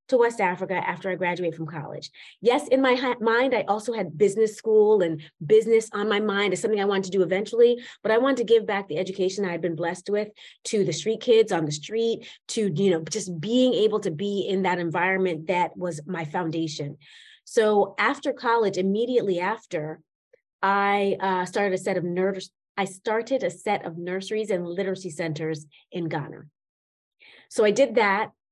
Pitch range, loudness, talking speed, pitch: 180-220 Hz, -24 LUFS, 195 wpm, 195 Hz